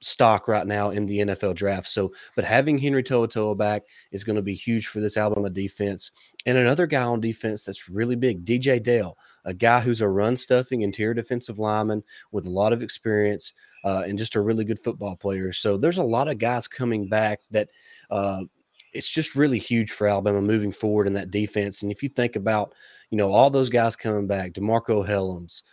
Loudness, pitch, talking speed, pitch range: -24 LUFS, 105 Hz, 210 wpm, 100-120 Hz